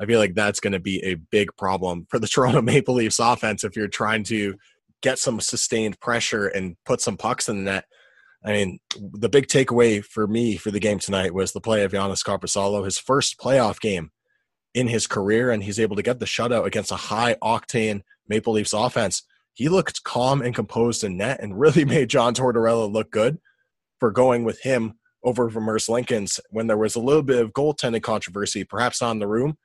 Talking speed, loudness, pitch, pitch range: 210 wpm, -22 LUFS, 110 Hz, 100-120 Hz